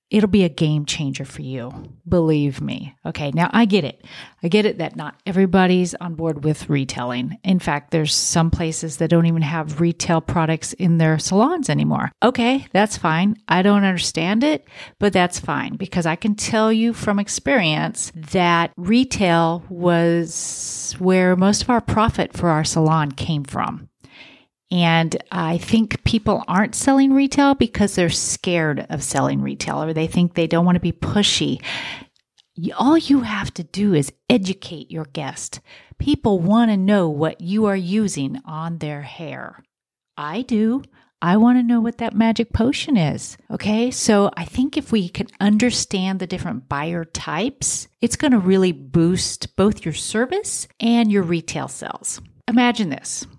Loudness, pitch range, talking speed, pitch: -19 LUFS, 160-215 Hz, 165 wpm, 180 Hz